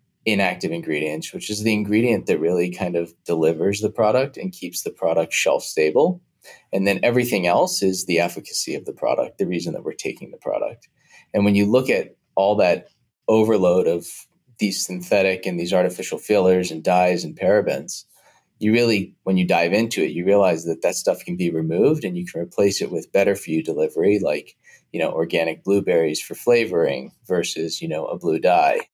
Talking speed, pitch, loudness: 195 wpm, 105 Hz, -21 LUFS